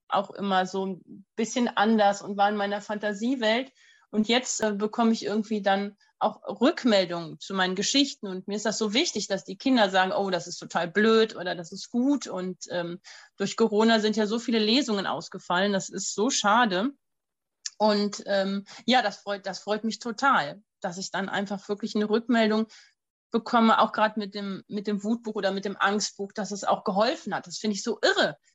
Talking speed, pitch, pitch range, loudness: 200 wpm, 210 Hz, 195-225 Hz, -26 LUFS